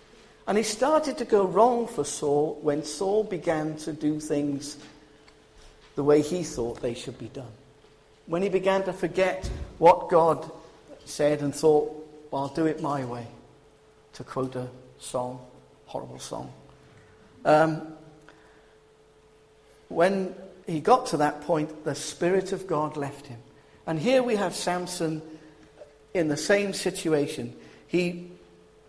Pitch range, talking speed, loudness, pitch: 145-180 Hz, 140 wpm, -26 LUFS, 155 Hz